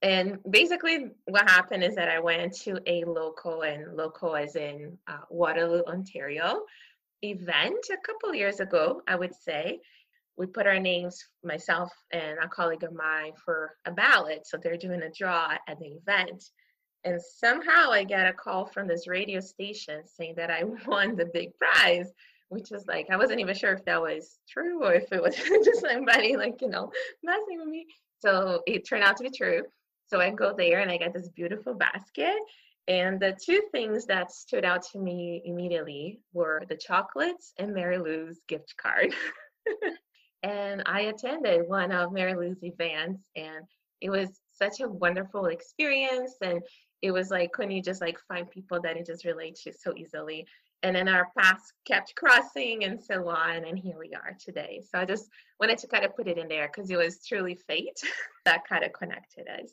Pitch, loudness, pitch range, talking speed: 185 Hz, -27 LUFS, 170-220 Hz, 190 wpm